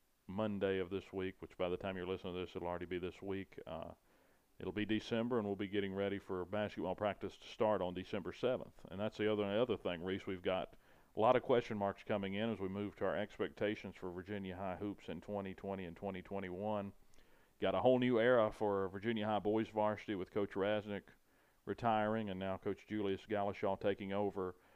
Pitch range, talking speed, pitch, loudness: 95-105 Hz, 210 wpm, 100 Hz, -40 LUFS